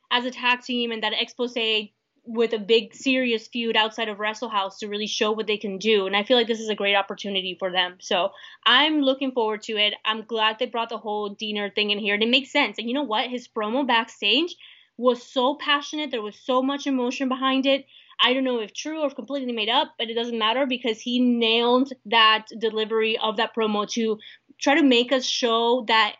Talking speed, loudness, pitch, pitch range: 225 wpm, -23 LUFS, 230 Hz, 215-255 Hz